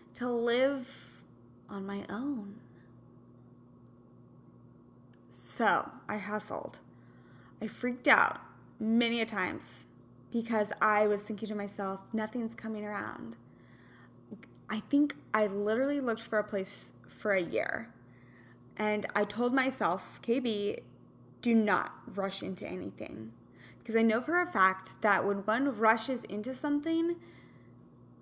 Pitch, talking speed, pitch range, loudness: 215 Hz, 120 wpm, 200-240 Hz, -32 LUFS